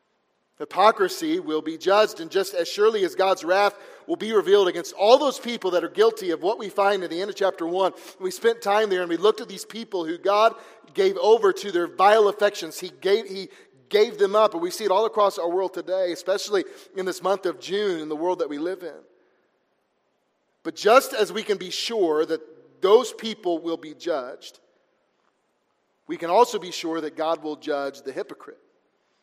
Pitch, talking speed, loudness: 200 Hz, 205 wpm, -23 LUFS